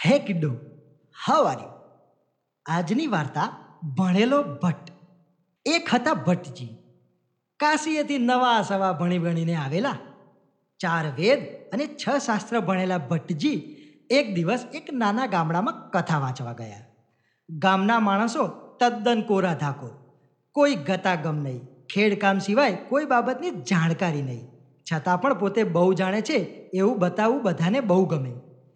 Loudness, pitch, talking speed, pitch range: -24 LUFS, 185 Hz, 120 wpm, 150-230 Hz